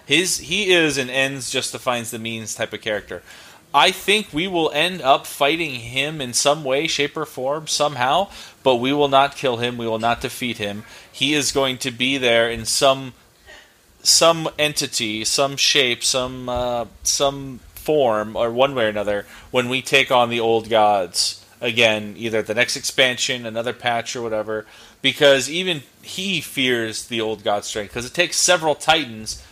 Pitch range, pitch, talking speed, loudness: 115-145 Hz, 125 Hz, 180 wpm, -19 LUFS